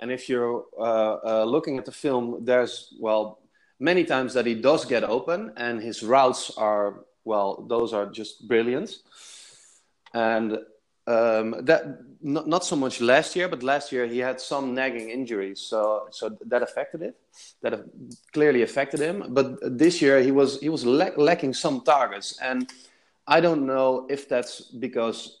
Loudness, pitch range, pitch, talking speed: -24 LUFS, 115-135 Hz, 125 Hz, 170 wpm